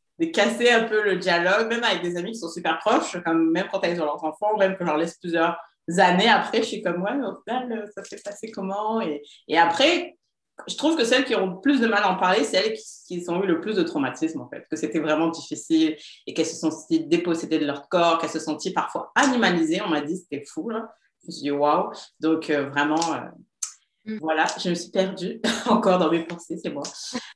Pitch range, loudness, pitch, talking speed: 160-220 Hz, -23 LUFS, 180 Hz, 245 wpm